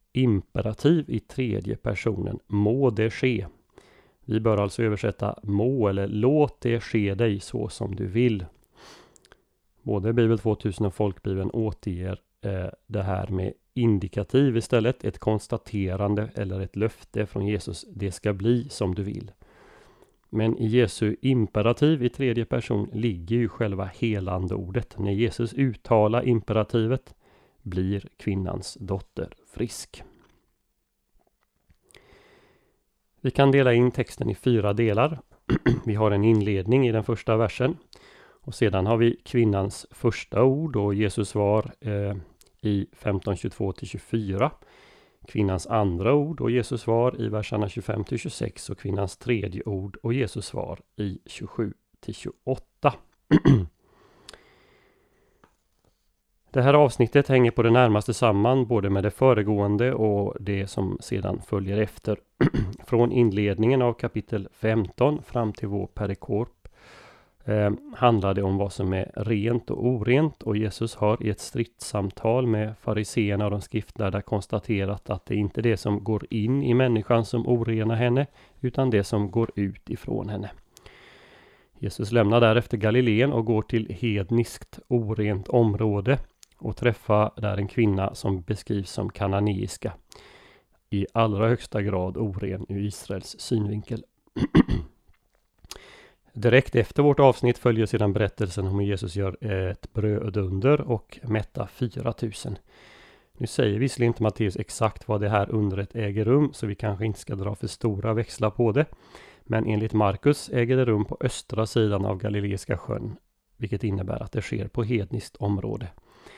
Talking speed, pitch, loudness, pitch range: 140 wpm, 110 Hz, -25 LUFS, 100-120 Hz